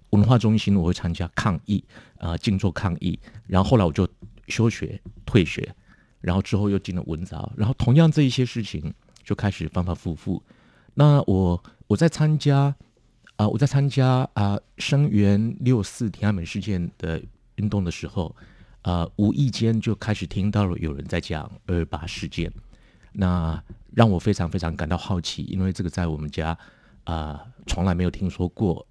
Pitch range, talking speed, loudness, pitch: 85-110 Hz, 265 characters per minute, -24 LUFS, 100 Hz